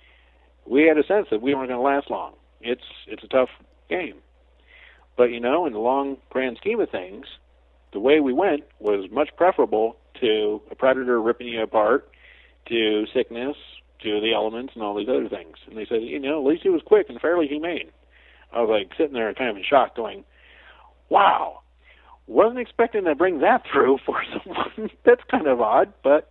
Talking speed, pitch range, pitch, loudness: 195 wpm, 105-145 Hz, 120 Hz, -22 LUFS